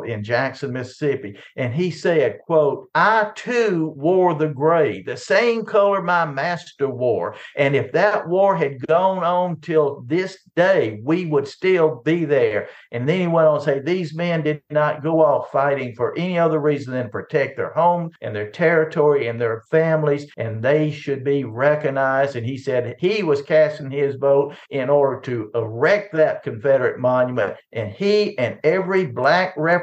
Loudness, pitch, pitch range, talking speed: -20 LUFS, 155 Hz, 140-175 Hz, 175 wpm